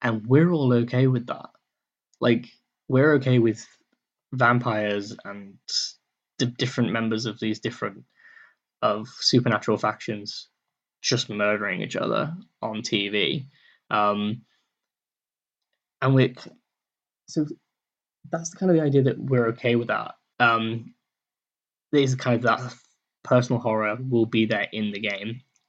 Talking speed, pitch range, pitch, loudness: 125 wpm, 110-130 Hz, 120 Hz, -24 LUFS